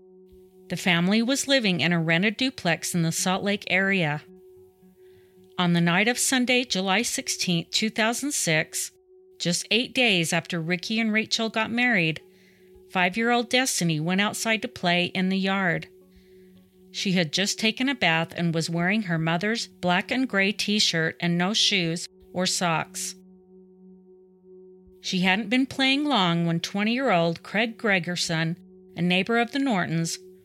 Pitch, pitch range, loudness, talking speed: 185 Hz, 175-220 Hz, -24 LUFS, 155 wpm